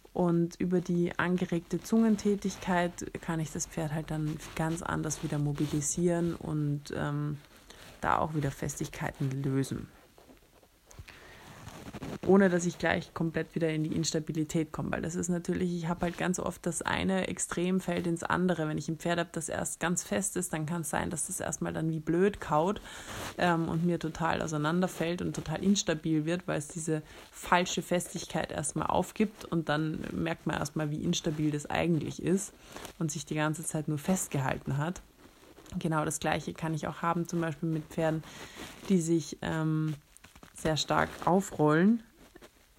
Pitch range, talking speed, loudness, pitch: 155-175 Hz, 165 wpm, -31 LUFS, 165 Hz